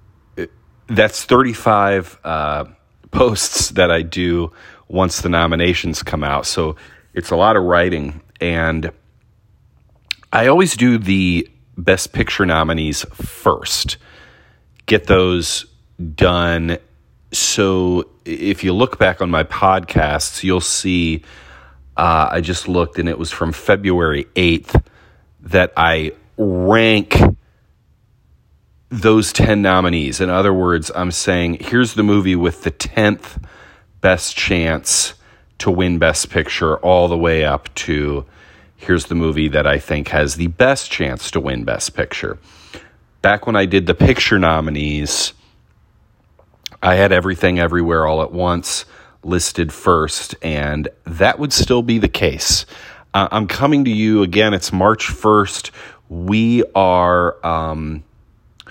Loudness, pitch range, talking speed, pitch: -16 LUFS, 80-100 Hz, 130 wpm, 90 Hz